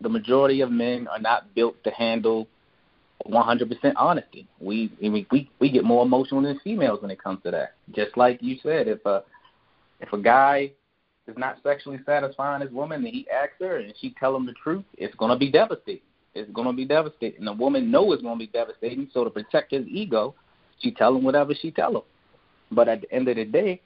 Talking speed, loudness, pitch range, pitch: 220 wpm, -24 LUFS, 115-150 Hz, 130 Hz